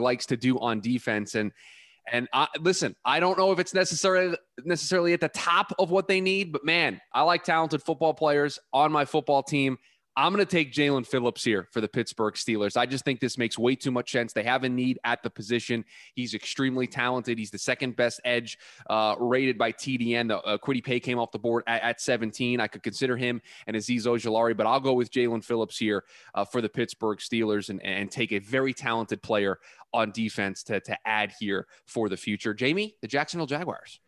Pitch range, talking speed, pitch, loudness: 115-145 Hz, 215 wpm, 125 Hz, -27 LUFS